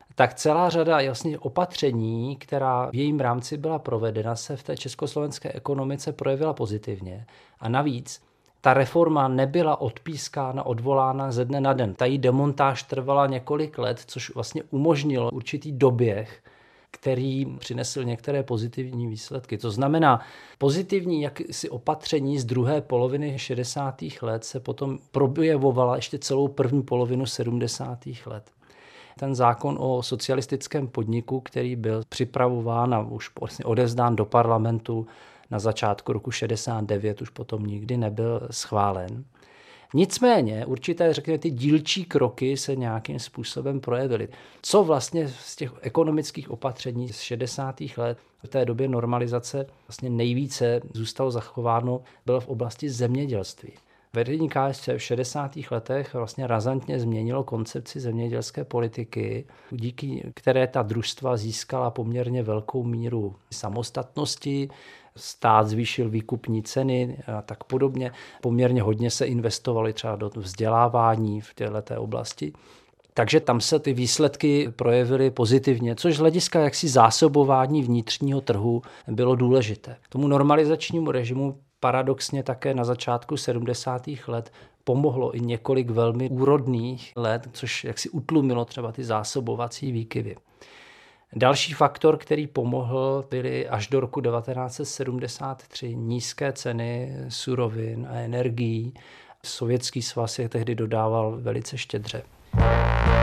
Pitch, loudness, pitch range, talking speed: 125 Hz, -25 LUFS, 120-140 Hz, 125 wpm